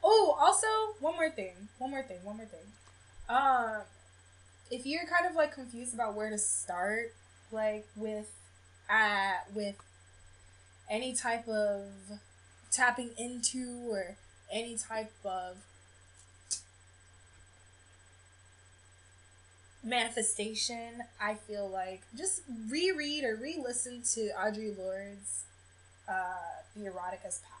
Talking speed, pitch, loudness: 115 wpm, 210 Hz, -34 LUFS